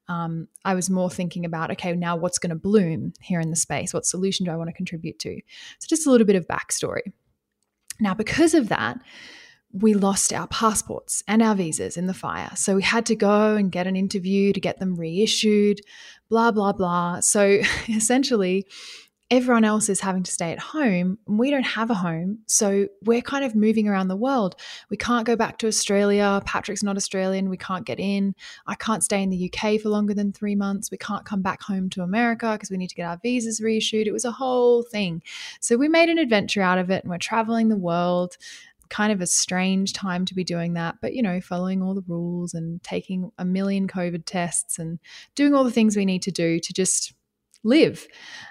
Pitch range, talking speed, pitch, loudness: 180-225 Hz, 215 wpm, 200 Hz, -23 LUFS